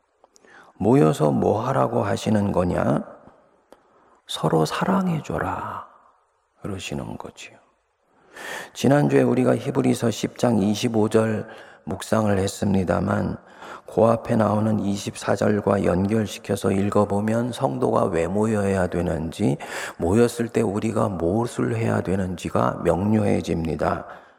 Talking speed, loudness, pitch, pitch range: 235 characters per minute, -22 LUFS, 105 Hz, 95-115 Hz